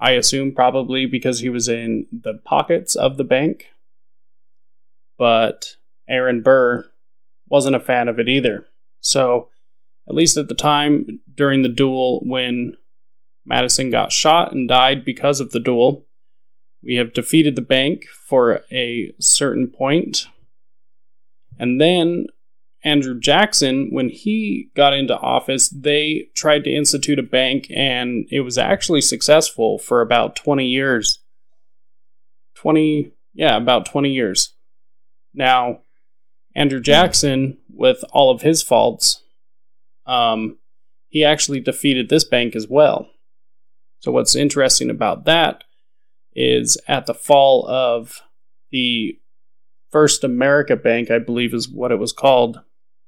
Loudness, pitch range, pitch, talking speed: -17 LUFS, 120-145 Hz, 130 Hz, 130 wpm